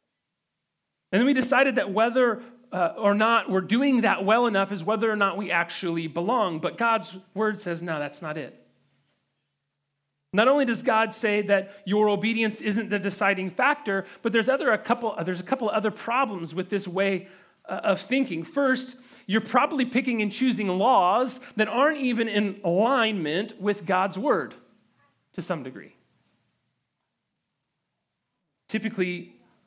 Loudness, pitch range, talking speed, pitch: -25 LUFS, 185-235 Hz, 160 wpm, 210 Hz